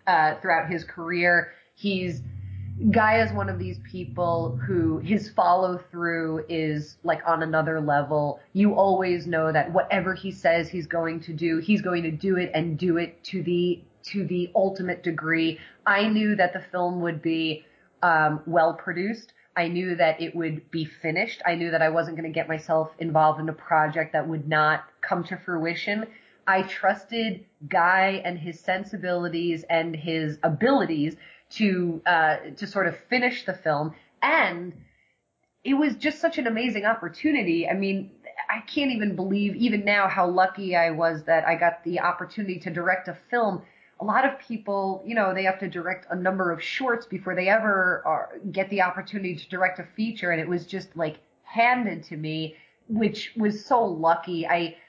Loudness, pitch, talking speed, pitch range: -25 LUFS, 175 Hz, 180 wpm, 165-195 Hz